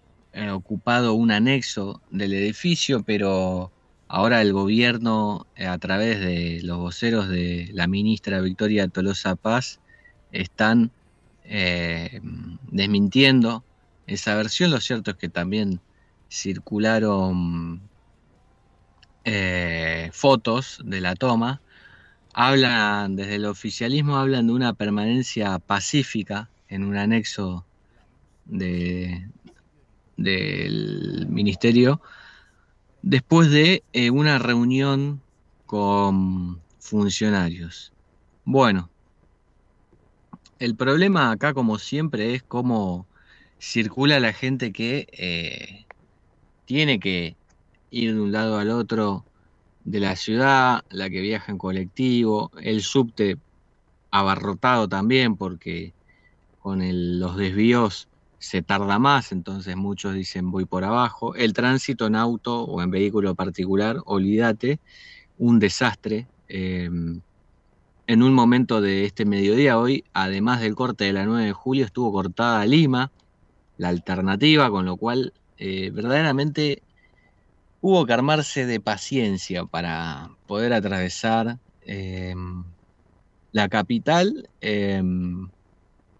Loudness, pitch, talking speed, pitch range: -22 LUFS, 105 Hz, 105 wpm, 95-120 Hz